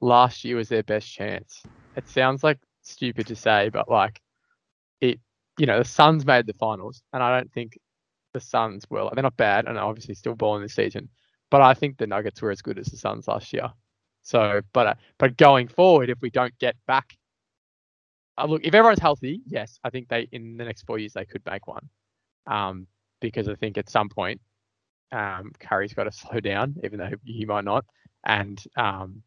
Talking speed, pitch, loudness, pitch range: 205 wpm, 115 Hz, -23 LUFS, 105-130 Hz